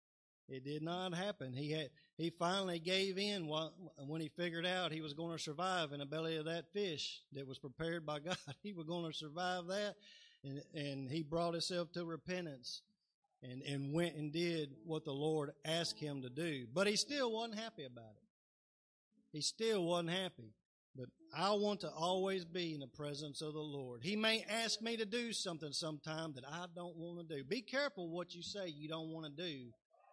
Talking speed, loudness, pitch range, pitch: 205 wpm, -42 LUFS, 150-185 Hz, 165 Hz